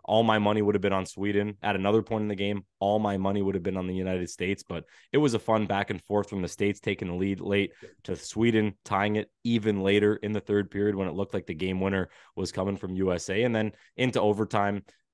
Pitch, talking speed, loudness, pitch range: 100 Hz, 255 wpm, -28 LUFS, 95-105 Hz